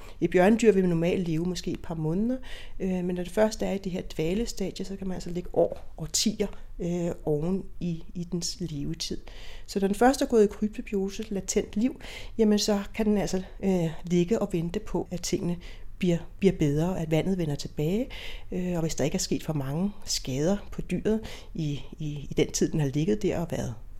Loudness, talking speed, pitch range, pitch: -28 LUFS, 215 wpm, 165-200 Hz, 180 Hz